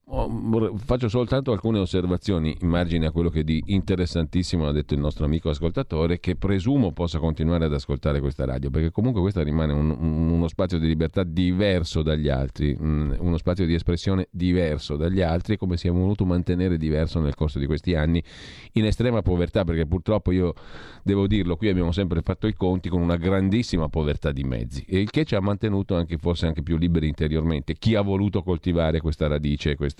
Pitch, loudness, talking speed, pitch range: 85 Hz, -24 LUFS, 190 wpm, 80-95 Hz